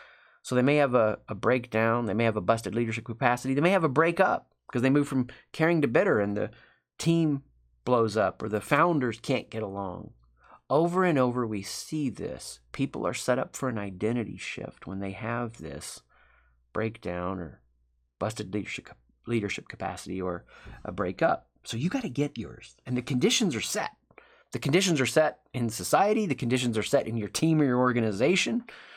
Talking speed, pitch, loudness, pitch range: 190 wpm, 120 Hz, -28 LUFS, 105-140 Hz